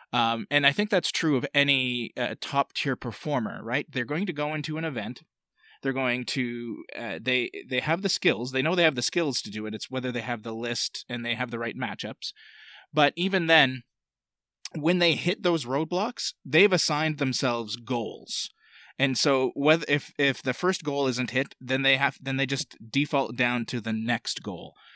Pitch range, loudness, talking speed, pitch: 120-155 Hz, -26 LUFS, 200 wpm, 135 Hz